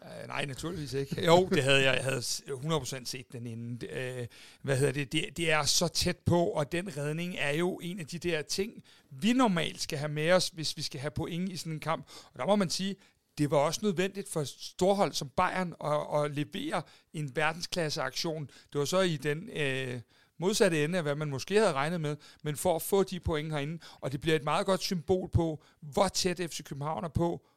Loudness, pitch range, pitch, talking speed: -31 LUFS, 145-180 Hz, 155 Hz, 220 wpm